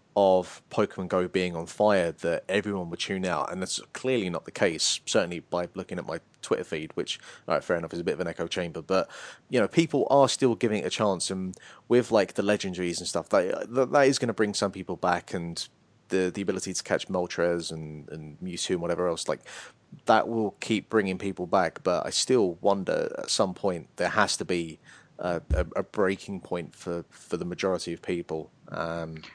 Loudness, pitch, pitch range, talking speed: -28 LUFS, 95 Hz, 85-105 Hz, 215 wpm